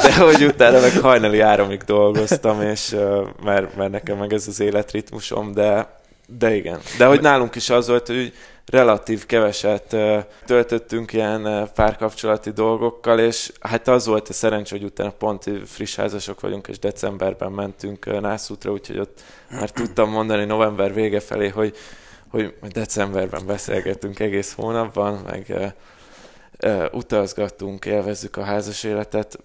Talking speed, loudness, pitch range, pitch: 140 wpm, -19 LUFS, 100-110 Hz, 105 Hz